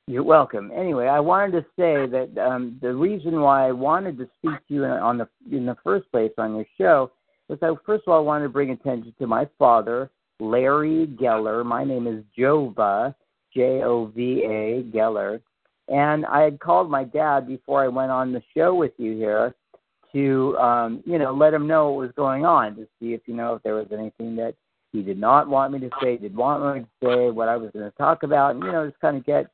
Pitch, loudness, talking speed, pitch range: 130 Hz, -22 LUFS, 225 wpm, 115-145 Hz